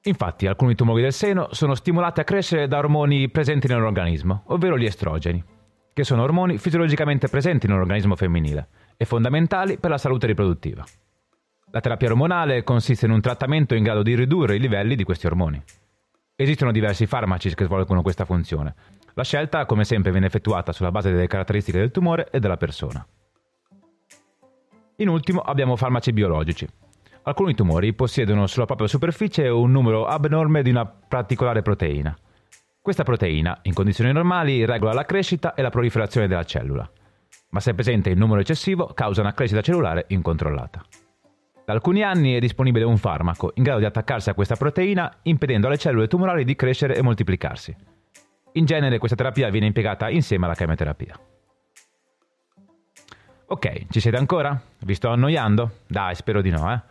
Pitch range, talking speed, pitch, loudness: 100-145 Hz, 160 wpm, 115 Hz, -21 LUFS